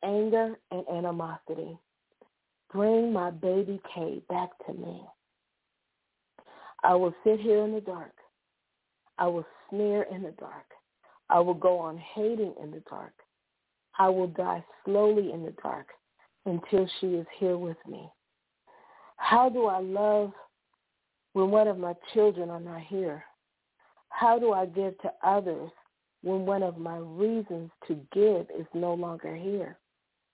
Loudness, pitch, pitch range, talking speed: -29 LUFS, 190 Hz, 175-210 Hz, 145 wpm